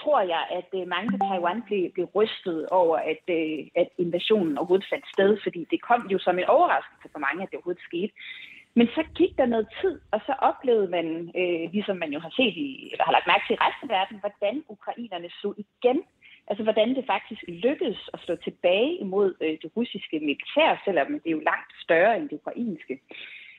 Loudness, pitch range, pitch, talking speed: -26 LUFS, 180-250 Hz, 205 Hz, 200 wpm